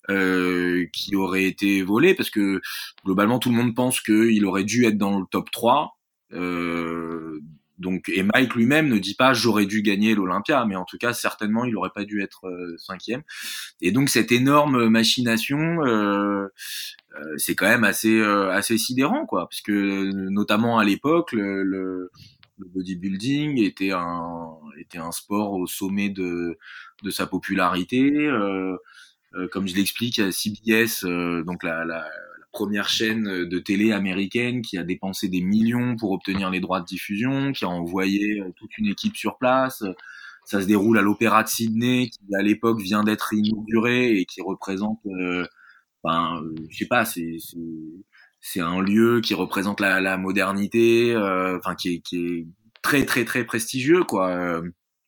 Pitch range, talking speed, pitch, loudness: 90-115 Hz, 170 wpm, 100 Hz, -22 LUFS